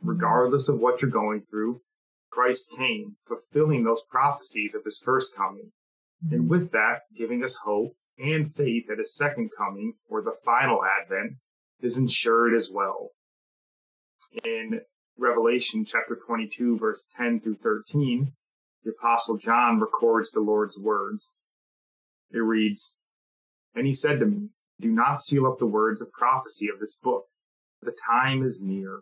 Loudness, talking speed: -25 LUFS, 150 wpm